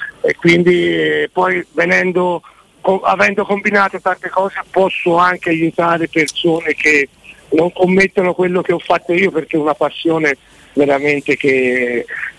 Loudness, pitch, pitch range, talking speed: -14 LUFS, 175 Hz, 150-185 Hz, 135 wpm